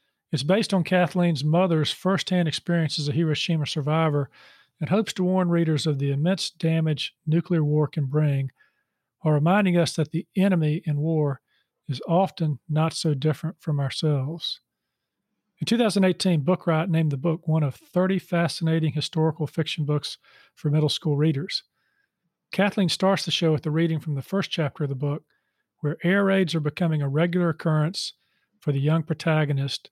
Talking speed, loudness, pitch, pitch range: 165 wpm, -24 LUFS, 160 Hz, 150-180 Hz